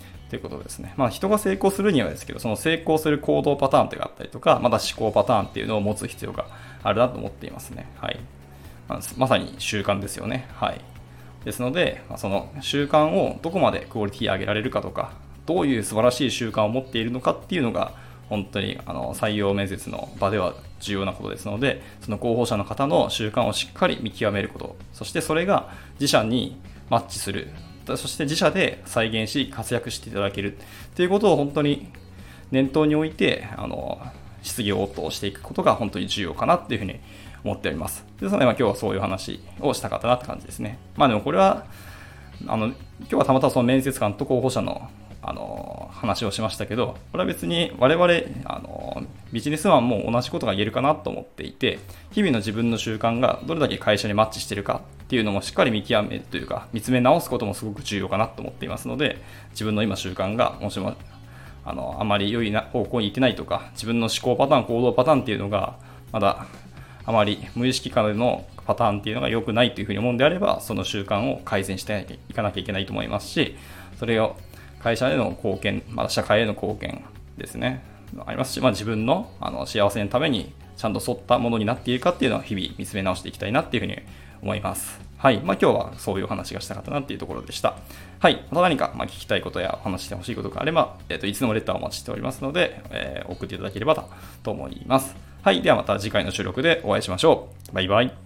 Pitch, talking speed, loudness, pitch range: 110 Hz, 445 characters per minute, -24 LUFS, 100-125 Hz